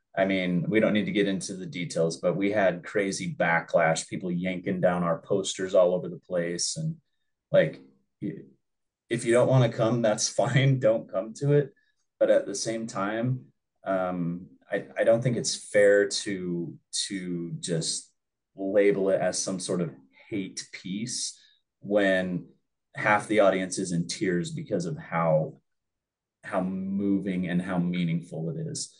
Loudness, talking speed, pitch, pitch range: -27 LUFS, 160 wpm, 95 Hz, 85-110 Hz